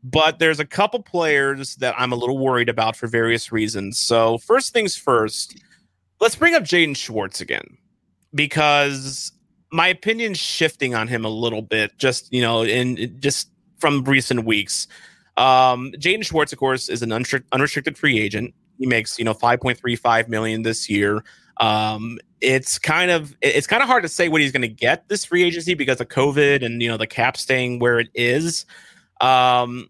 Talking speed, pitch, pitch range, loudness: 185 wpm, 130 Hz, 115-160 Hz, -19 LUFS